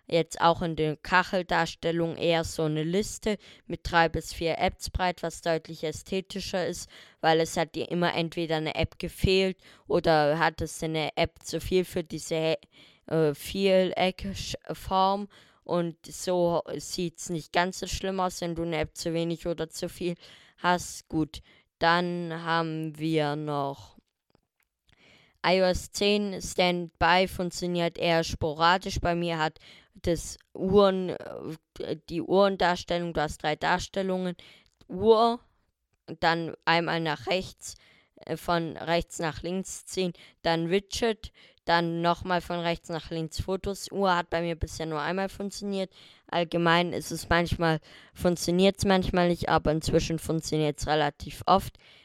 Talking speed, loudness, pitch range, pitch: 140 wpm, -28 LUFS, 160-180 Hz, 170 Hz